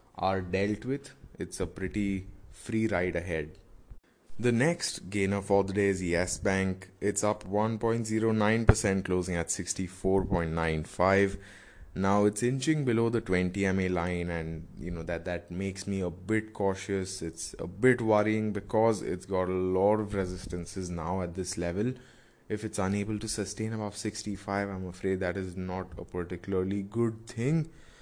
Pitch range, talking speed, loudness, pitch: 90-105 Hz, 155 wpm, -30 LUFS, 95 Hz